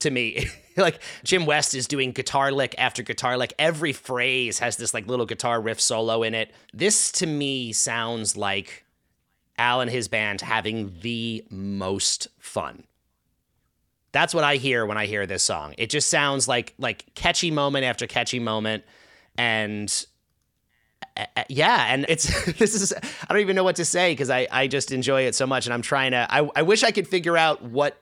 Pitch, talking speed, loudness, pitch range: 125 Hz, 195 wpm, -23 LUFS, 115-145 Hz